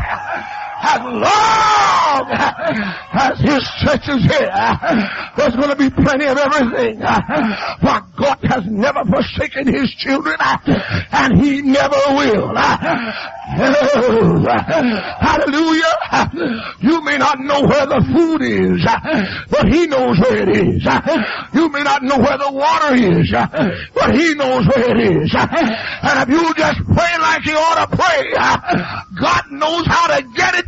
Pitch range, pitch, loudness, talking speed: 270-325 Hz, 285 Hz, -14 LUFS, 135 wpm